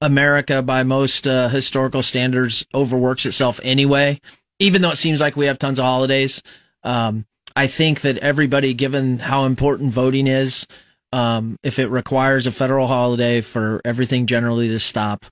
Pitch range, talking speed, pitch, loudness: 125-140 Hz, 160 wpm, 130 Hz, -18 LUFS